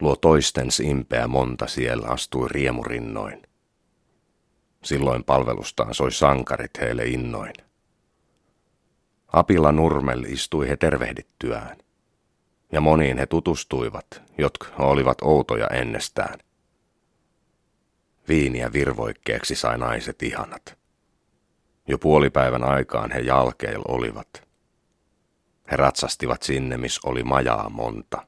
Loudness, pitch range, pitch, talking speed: -23 LUFS, 60-70 Hz, 65 Hz, 95 wpm